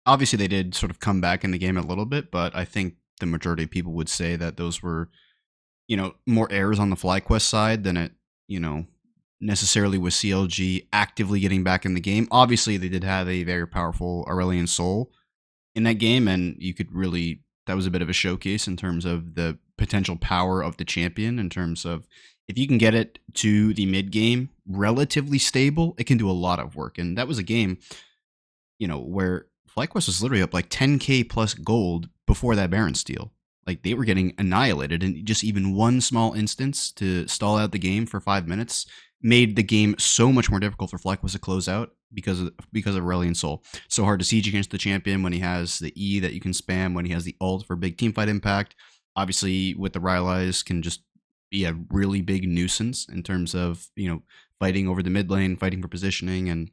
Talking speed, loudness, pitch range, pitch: 220 wpm, -24 LUFS, 90-105 Hz, 95 Hz